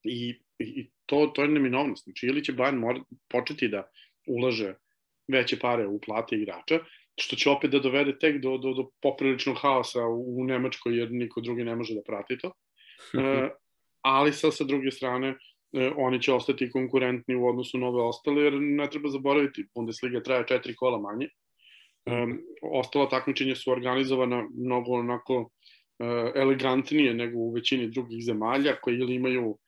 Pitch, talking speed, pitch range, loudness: 130 Hz, 165 wpm, 120-140 Hz, -28 LUFS